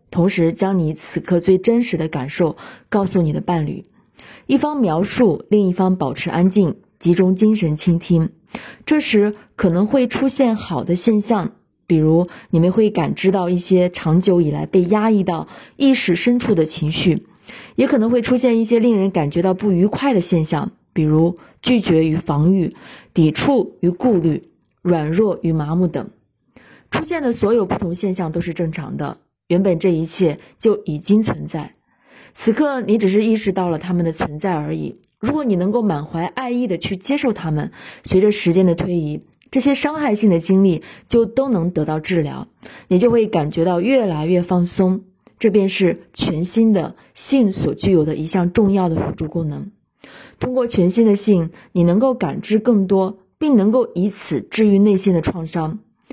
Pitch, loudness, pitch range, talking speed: 185 Hz, -17 LUFS, 170-220 Hz, 260 characters per minute